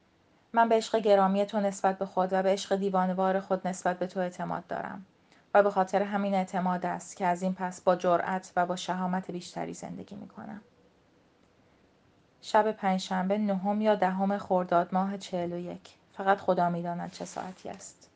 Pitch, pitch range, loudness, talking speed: 190 Hz, 180-200 Hz, -29 LUFS, 175 wpm